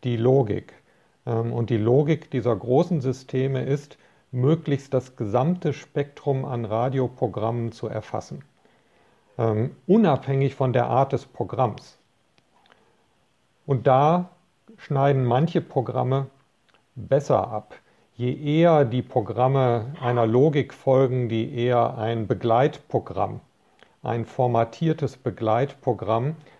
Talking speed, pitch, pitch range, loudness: 100 wpm, 130 Hz, 120-140 Hz, -23 LUFS